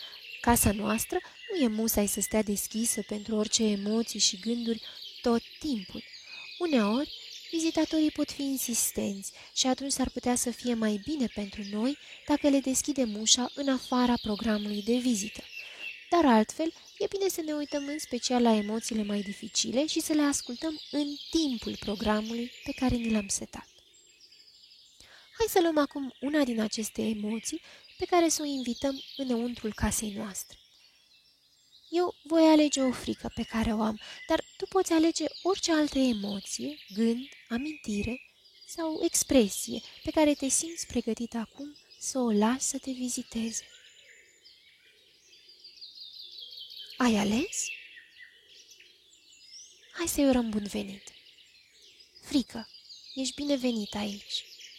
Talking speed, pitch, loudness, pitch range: 135 wpm, 260 Hz, -29 LUFS, 225-320 Hz